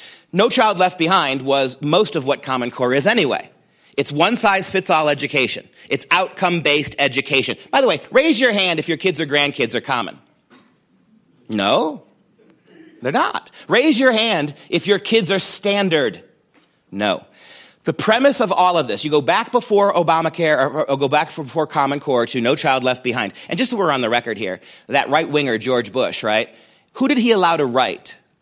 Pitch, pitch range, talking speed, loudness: 160 Hz, 140-200 Hz, 190 wpm, -17 LUFS